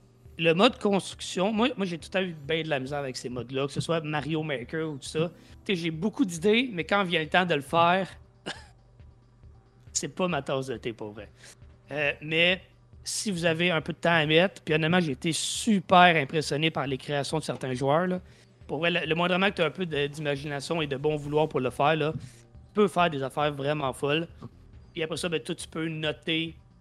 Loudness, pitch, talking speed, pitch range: -27 LUFS, 160 Hz, 230 wpm, 140-175 Hz